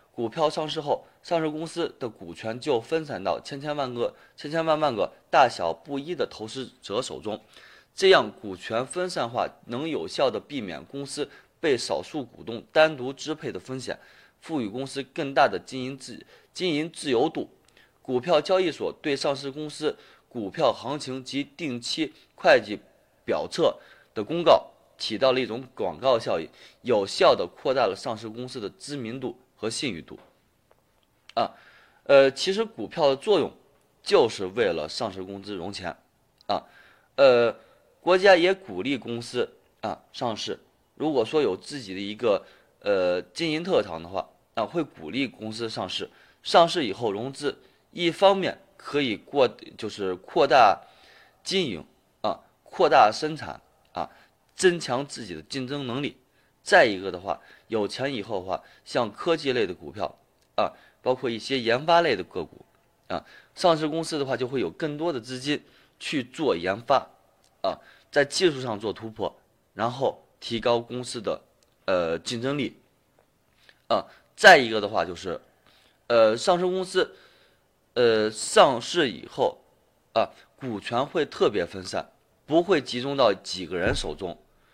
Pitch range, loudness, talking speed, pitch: 120-165 Hz, -26 LUFS, 225 characters per minute, 140 Hz